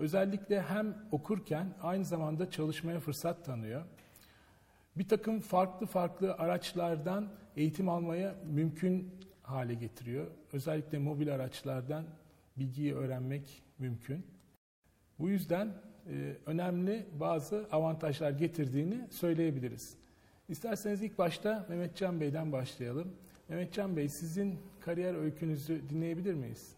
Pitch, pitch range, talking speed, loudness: 165 Hz, 145-185 Hz, 105 wpm, -37 LUFS